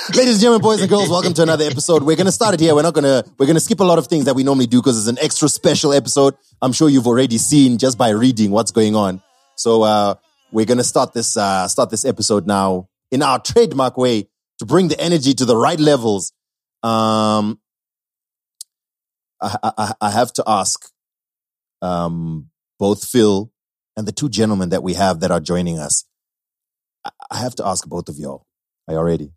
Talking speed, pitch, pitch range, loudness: 215 wpm, 125 Hz, 105-155 Hz, -16 LUFS